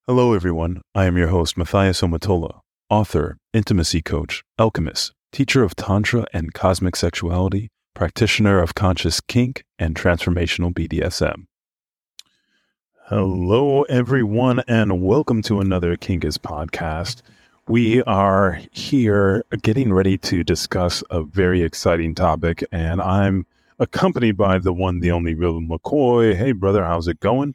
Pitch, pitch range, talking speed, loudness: 95 Hz, 85-110 Hz, 130 wpm, -19 LUFS